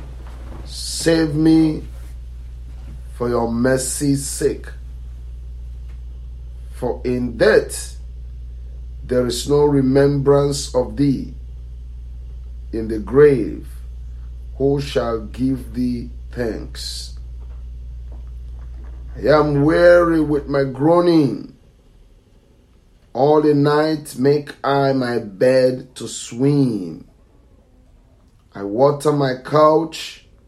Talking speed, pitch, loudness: 85 wpm, 115 Hz, -18 LUFS